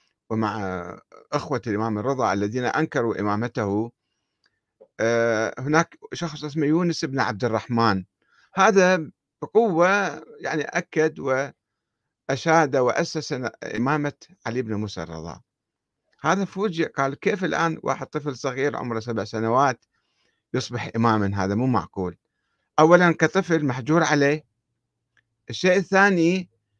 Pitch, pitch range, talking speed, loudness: 135 Hz, 115-165 Hz, 105 wpm, -23 LUFS